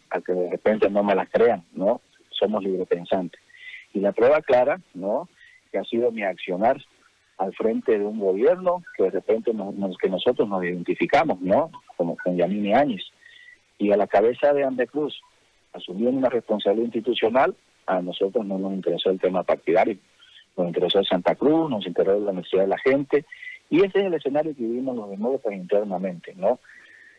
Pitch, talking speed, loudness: 120 Hz, 180 wpm, -23 LUFS